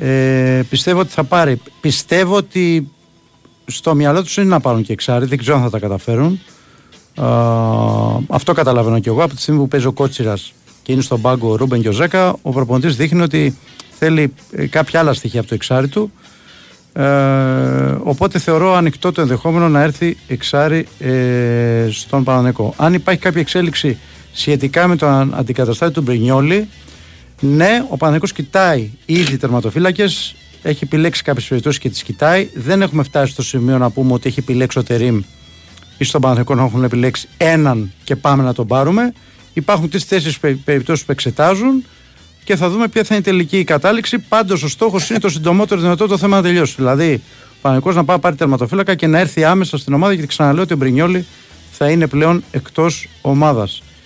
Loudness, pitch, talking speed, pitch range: -14 LUFS, 145 Hz, 180 wpm, 125-170 Hz